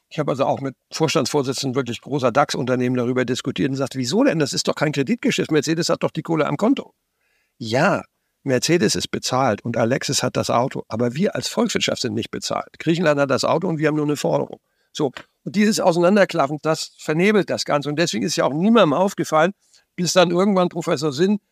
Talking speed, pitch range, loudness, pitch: 205 wpm, 135-175 Hz, -20 LUFS, 155 Hz